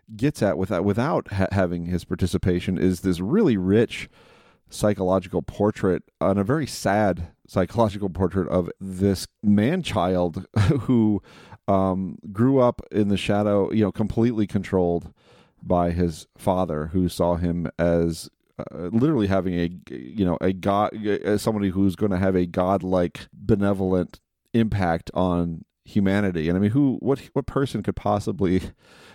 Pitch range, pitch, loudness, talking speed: 90-105 Hz, 95 Hz, -23 LUFS, 145 wpm